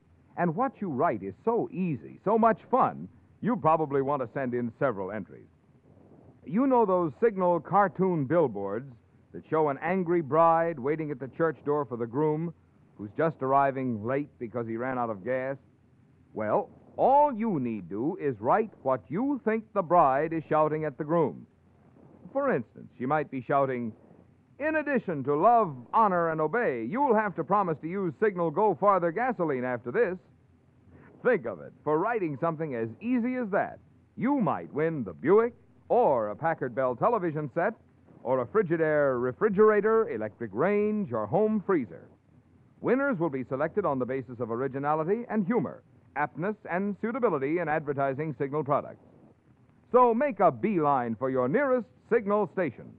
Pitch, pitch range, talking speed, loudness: 160 Hz, 130-210 Hz, 165 wpm, -28 LUFS